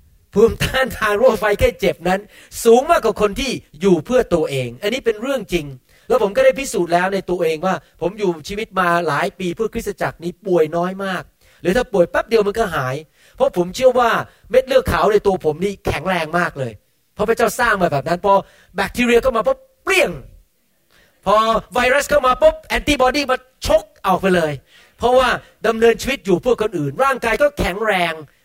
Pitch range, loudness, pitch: 175-250 Hz, -17 LUFS, 205 Hz